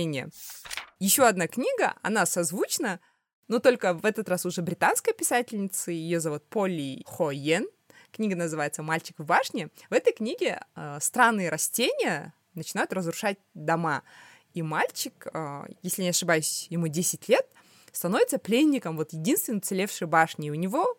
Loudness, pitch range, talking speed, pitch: -27 LUFS, 165-230 Hz, 140 wpm, 180 Hz